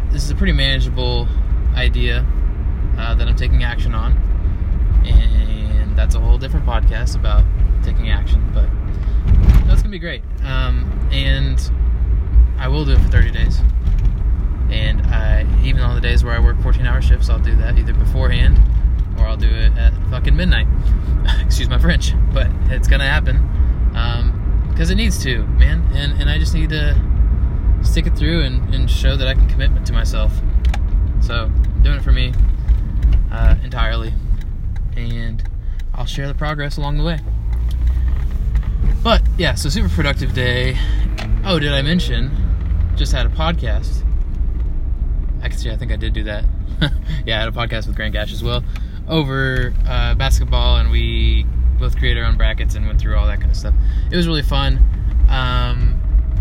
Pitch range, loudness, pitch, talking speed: 65-90 Hz, -18 LUFS, 70 Hz, 170 wpm